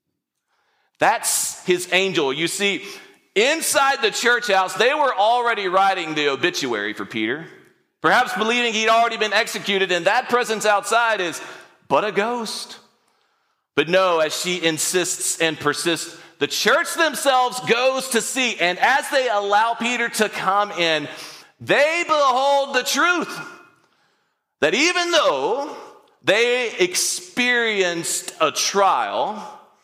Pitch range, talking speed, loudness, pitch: 180-275 Hz, 125 wpm, -19 LUFS, 225 Hz